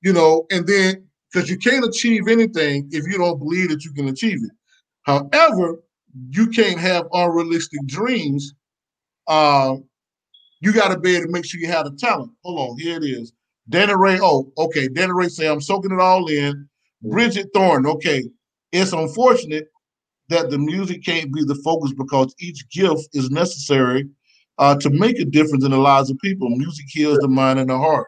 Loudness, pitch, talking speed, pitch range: -18 LUFS, 160 Hz, 190 wpm, 140-185 Hz